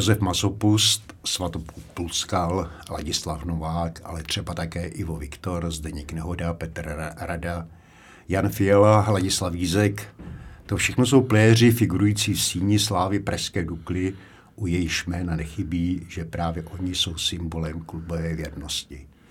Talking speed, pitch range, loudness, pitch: 120 wpm, 85-100 Hz, -24 LUFS, 90 Hz